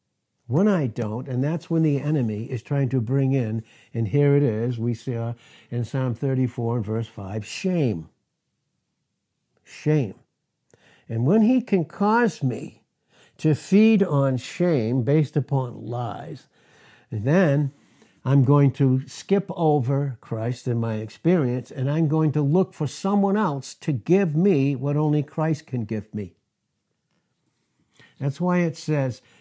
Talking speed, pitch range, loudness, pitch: 145 wpm, 120-155 Hz, -23 LUFS, 140 Hz